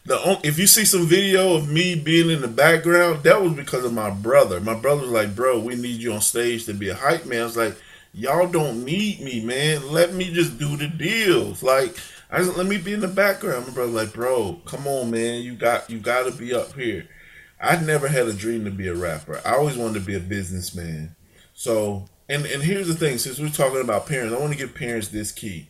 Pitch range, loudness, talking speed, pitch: 115-170 Hz, -21 LUFS, 250 wpm, 130 Hz